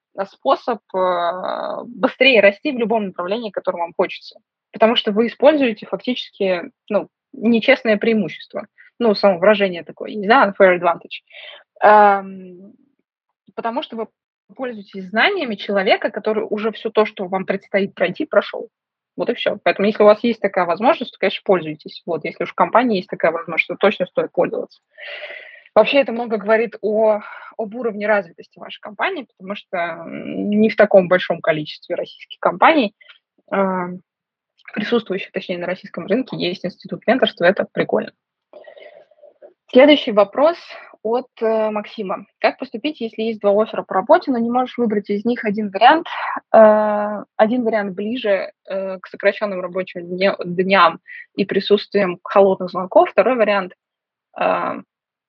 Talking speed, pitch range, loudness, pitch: 140 wpm, 195-235 Hz, -18 LUFS, 210 Hz